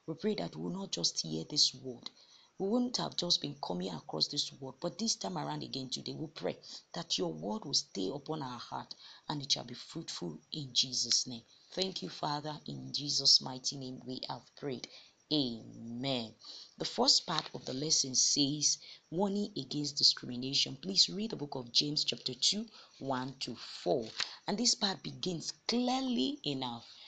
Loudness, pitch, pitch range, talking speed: -33 LUFS, 145 Hz, 130-175 Hz, 180 wpm